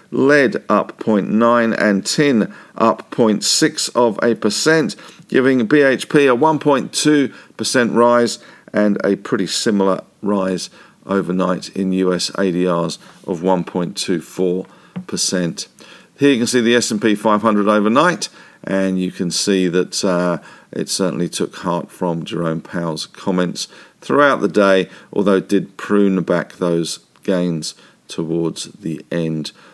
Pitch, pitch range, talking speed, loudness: 95 Hz, 90-115 Hz, 125 wpm, -17 LUFS